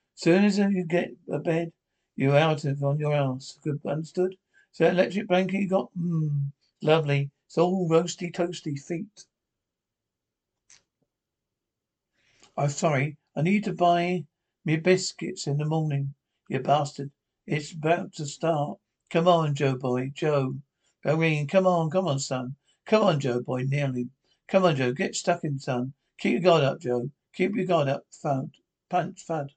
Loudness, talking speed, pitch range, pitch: -26 LUFS, 160 wpm, 140-175 Hz, 155 Hz